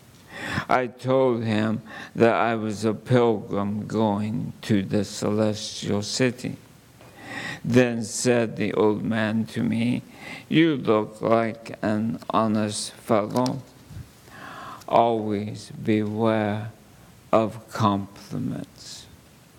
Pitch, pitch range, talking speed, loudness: 110 Hz, 105-115 Hz, 90 wpm, -24 LUFS